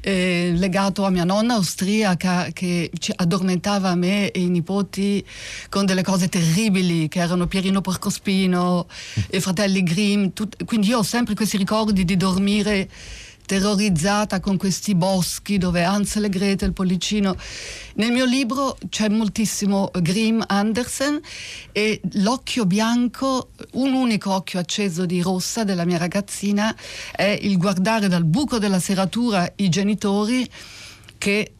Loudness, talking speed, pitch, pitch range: -21 LUFS, 135 wpm, 195 Hz, 185-210 Hz